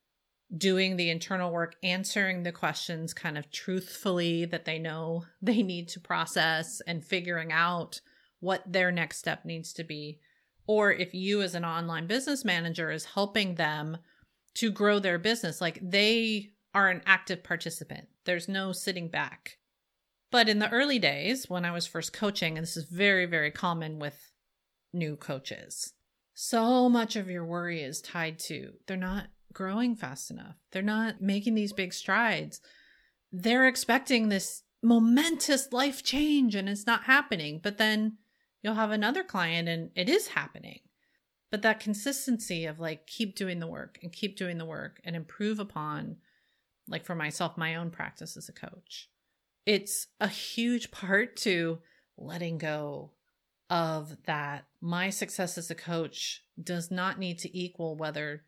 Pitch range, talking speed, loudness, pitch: 165-210 Hz, 160 wpm, -30 LUFS, 185 Hz